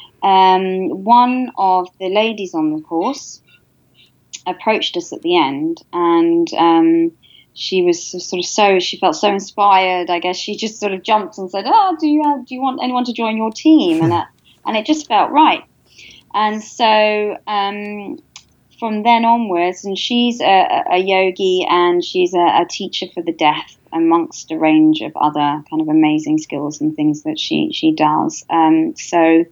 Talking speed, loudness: 180 wpm, -15 LUFS